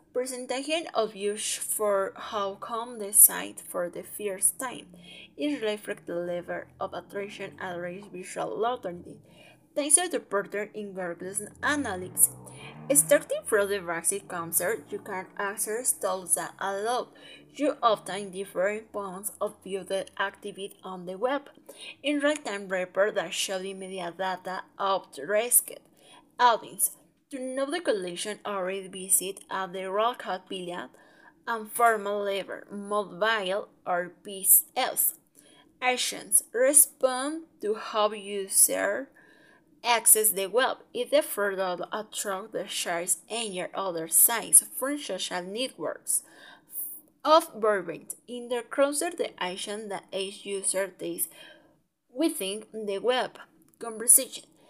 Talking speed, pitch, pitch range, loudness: 125 wpm, 200 Hz, 185-245 Hz, -26 LUFS